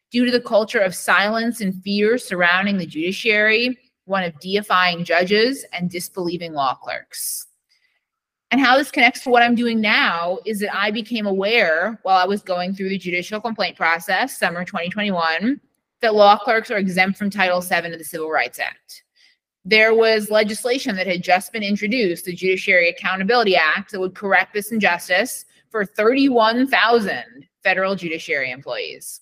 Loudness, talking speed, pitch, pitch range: -18 LUFS, 160 wpm, 205 Hz, 180-230 Hz